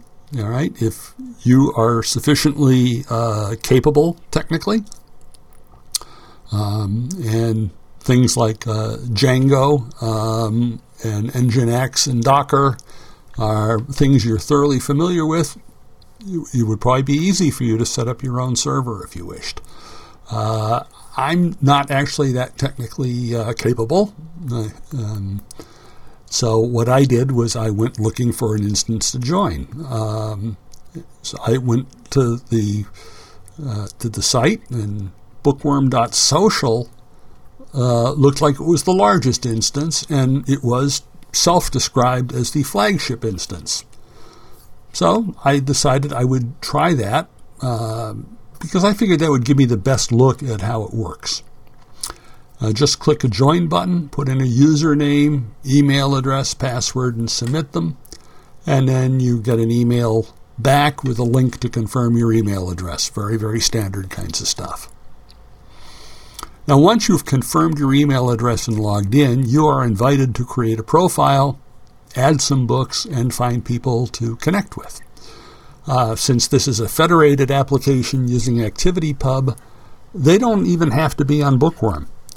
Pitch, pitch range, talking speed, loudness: 125 Hz, 115-145 Hz, 140 wpm, -17 LUFS